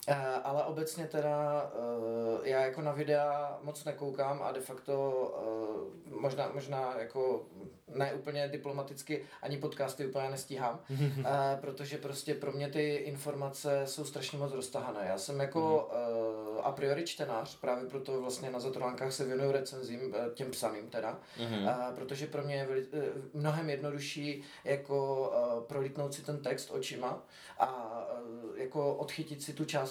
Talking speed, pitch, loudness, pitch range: 155 wpm, 140 Hz, -36 LUFS, 130-145 Hz